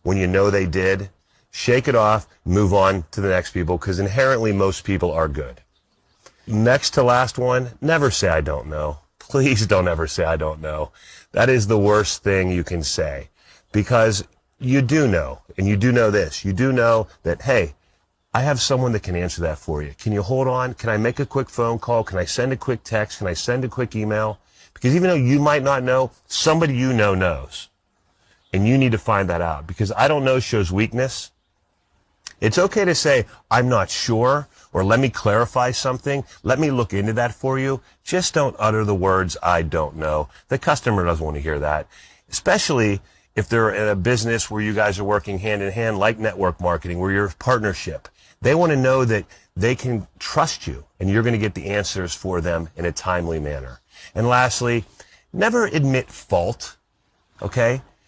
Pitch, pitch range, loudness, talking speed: 110 Hz, 95-125 Hz, -20 LUFS, 205 wpm